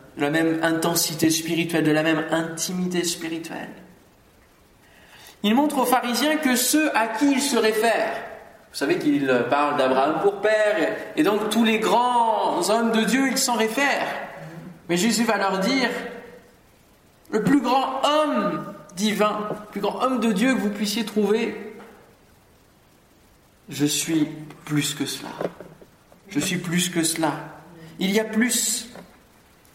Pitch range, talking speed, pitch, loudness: 165-230 Hz, 145 wpm, 210 Hz, -22 LUFS